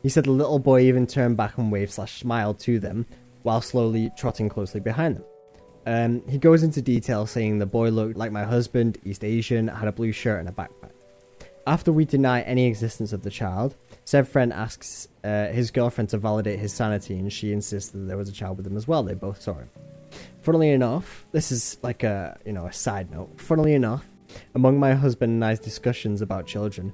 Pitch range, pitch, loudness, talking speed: 105-125 Hz, 115 Hz, -24 LUFS, 215 wpm